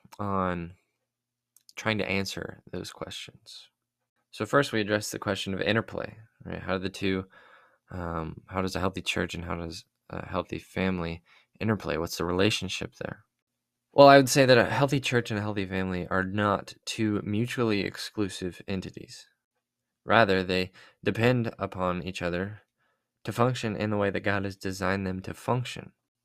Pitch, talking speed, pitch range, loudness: 100 Hz, 165 wpm, 95-110 Hz, -27 LUFS